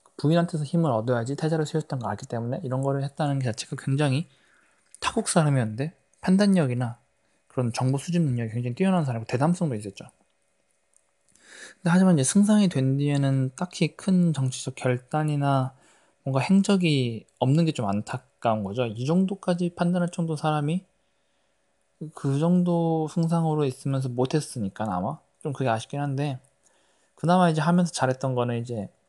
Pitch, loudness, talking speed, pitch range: 140 Hz, -25 LUFS, 350 characters per minute, 125-165 Hz